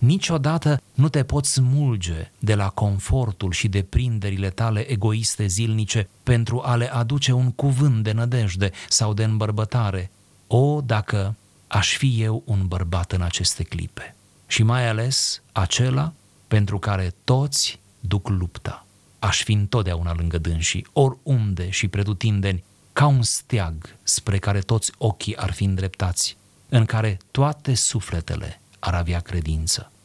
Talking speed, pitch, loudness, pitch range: 140 wpm, 110 Hz, -22 LUFS, 100-125 Hz